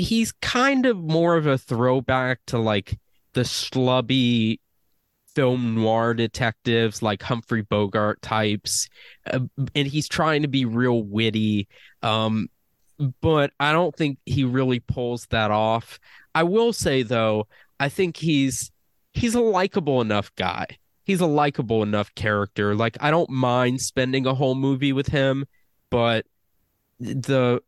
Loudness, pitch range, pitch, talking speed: -23 LUFS, 110-140 Hz, 125 Hz, 140 wpm